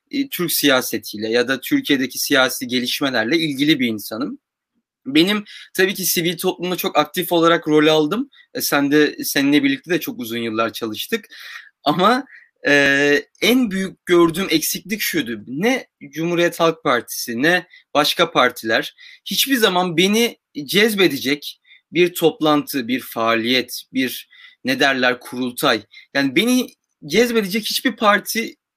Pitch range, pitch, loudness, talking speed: 140-210 Hz, 165 Hz, -18 LUFS, 125 wpm